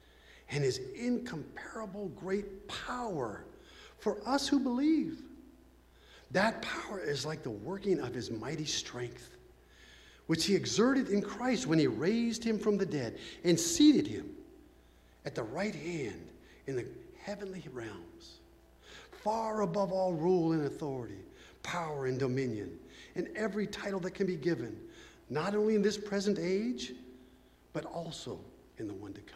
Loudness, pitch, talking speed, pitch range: -34 LUFS, 195 Hz, 145 wpm, 145-225 Hz